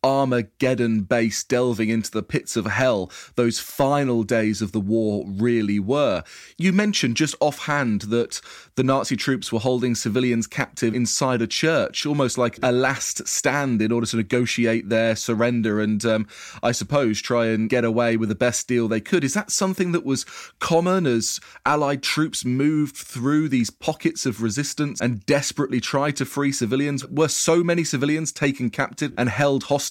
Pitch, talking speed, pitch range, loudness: 125 Hz, 175 wpm, 115-145 Hz, -22 LUFS